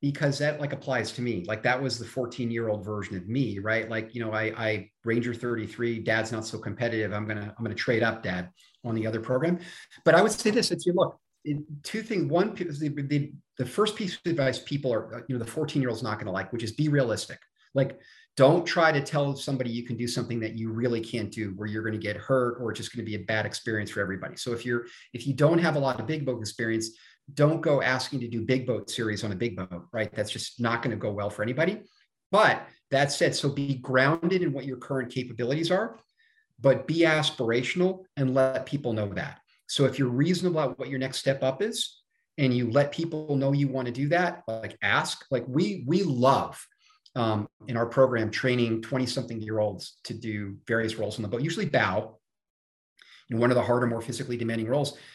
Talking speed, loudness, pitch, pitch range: 230 wpm, -28 LUFS, 125 Hz, 110-145 Hz